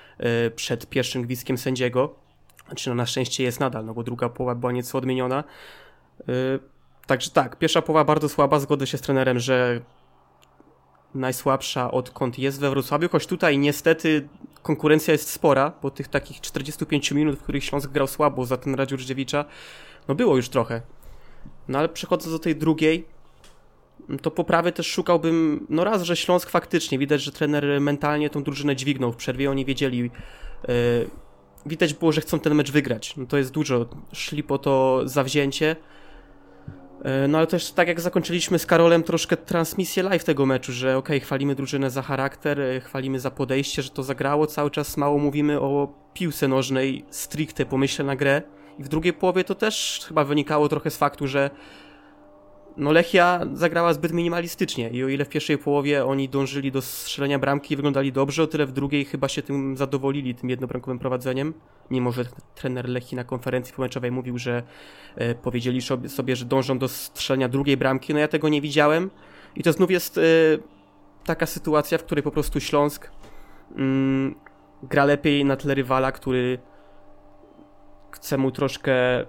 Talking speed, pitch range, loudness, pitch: 165 wpm, 130-155 Hz, -23 LUFS, 140 Hz